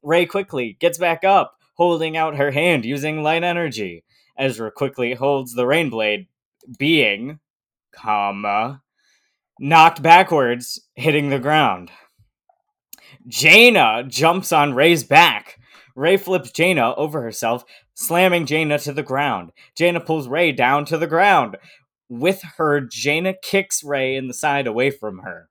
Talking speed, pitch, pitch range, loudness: 135 wpm, 150 Hz, 125-170 Hz, -17 LUFS